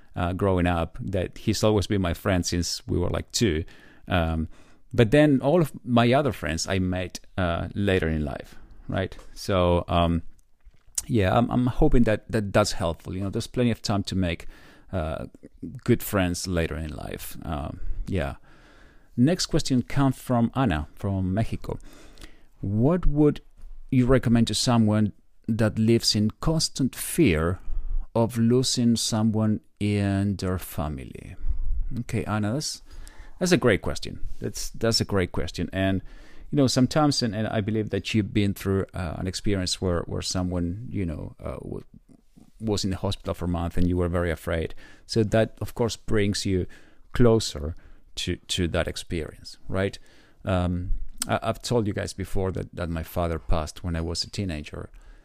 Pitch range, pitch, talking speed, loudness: 90-115 Hz, 100 Hz, 165 wpm, -25 LUFS